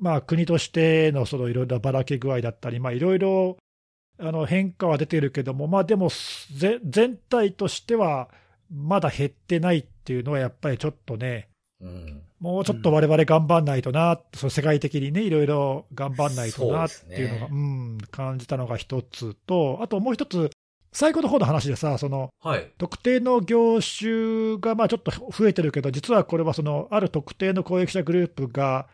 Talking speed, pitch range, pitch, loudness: 330 characters per minute, 130-185 Hz, 155 Hz, -24 LUFS